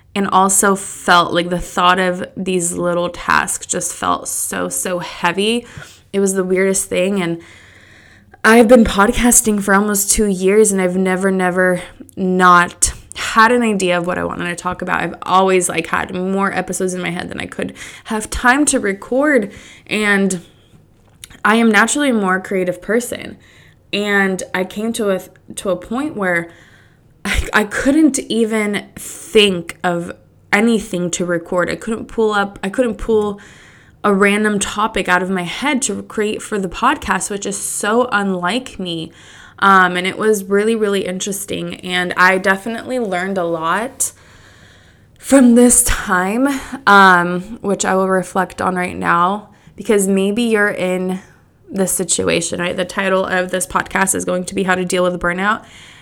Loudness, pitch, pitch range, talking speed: -15 LUFS, 190 Hz, 180-215 Hz, 165 wpm